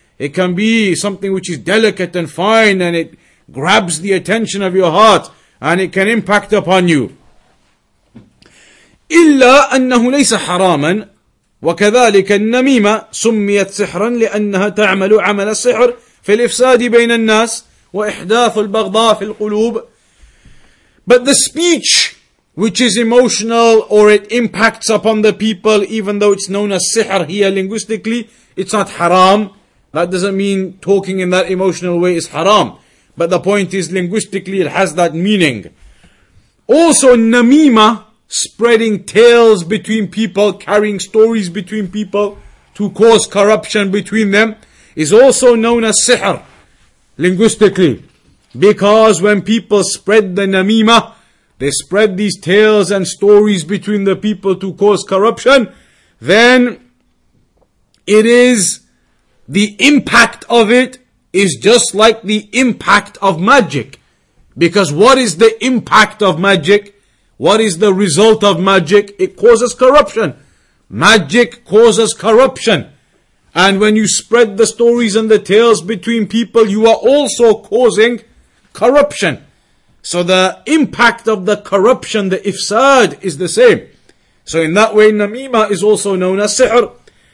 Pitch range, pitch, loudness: 190-225 Hz, 210 Hz, -11 LUFS